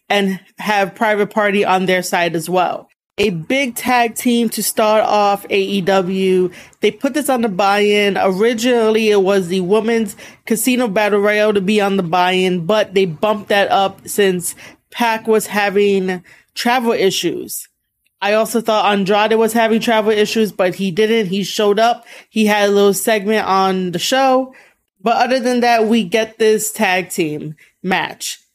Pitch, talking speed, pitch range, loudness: 210 Hz, 165 wpm, 195-225 Hz, -15 LUFS